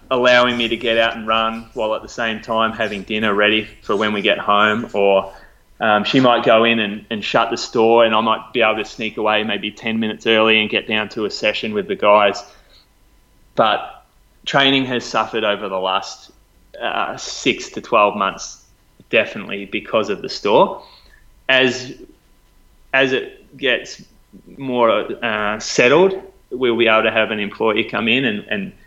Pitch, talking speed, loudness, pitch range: 110 Hz, 180 wpm, -17 LUFS, 105-120 Hz